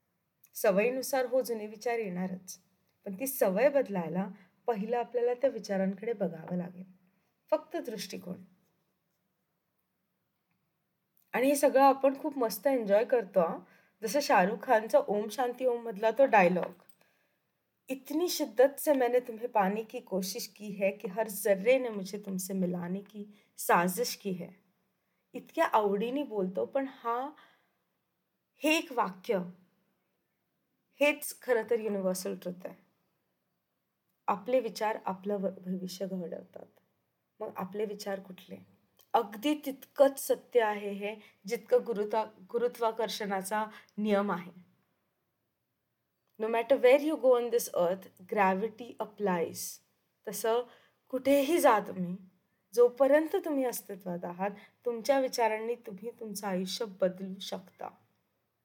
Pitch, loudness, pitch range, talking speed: 215 Hz, -31 LUFS, 190-245 Hz, 115 wpm